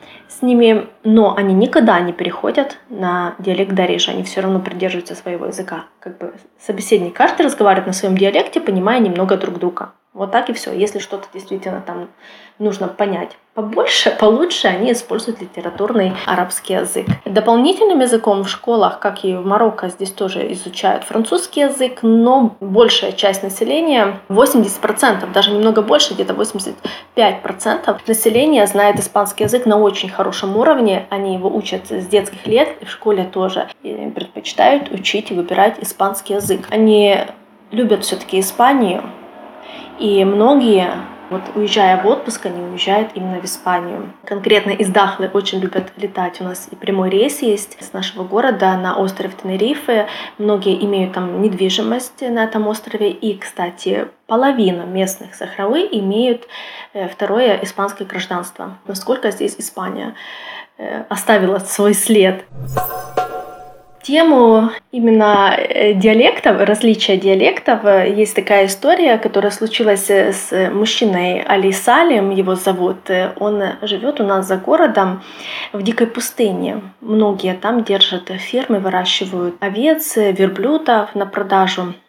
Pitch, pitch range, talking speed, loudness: 205 Hz, 190-225 Hz, 135 wpm, -15 LUFS